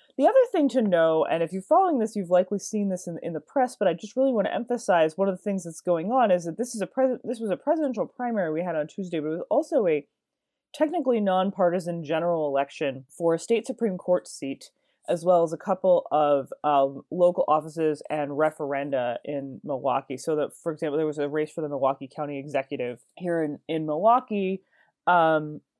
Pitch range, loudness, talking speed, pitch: 155-220 Hz, -26 LUFS, 215 wpm, 175 Hz